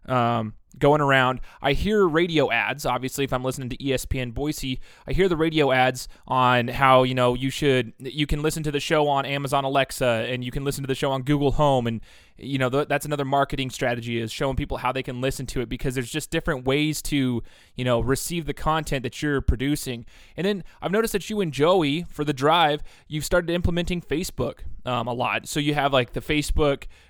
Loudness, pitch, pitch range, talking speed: -24 LUFS, 140 Hz, 130-150 Hz, 240 wpm